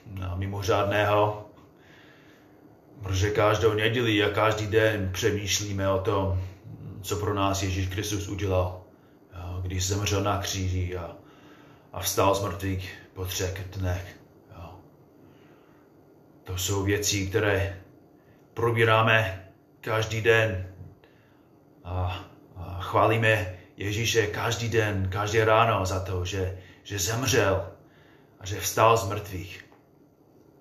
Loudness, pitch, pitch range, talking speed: -26 LUFS, 100 Hz, 95-110 Hz, 110 wpm